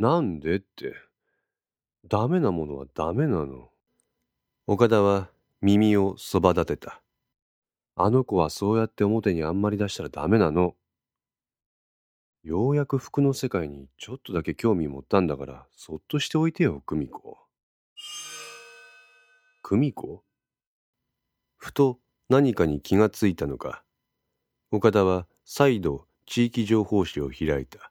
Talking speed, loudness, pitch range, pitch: 245 characters per minute, -25 LUFS, 80-135 Hz, 105 Hz